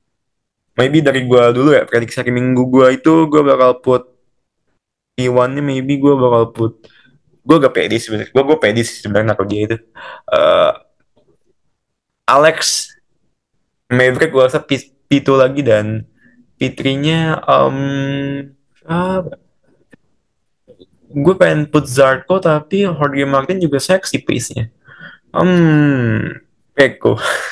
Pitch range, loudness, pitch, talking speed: 125-155 Hz, -13 LUFS, 135 Hz, 120 wpm